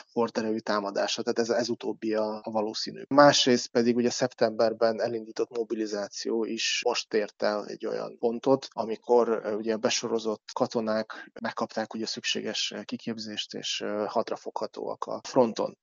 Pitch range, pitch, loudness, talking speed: 110-120 Hz, 115 Hz, -28 LUFS, 125 wpm